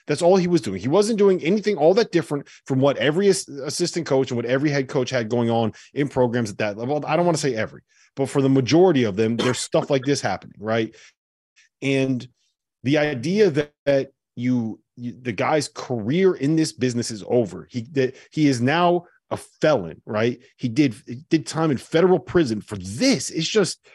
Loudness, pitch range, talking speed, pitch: -22 LUFS, 120-160 Hz, 205 wpm, 135 Hz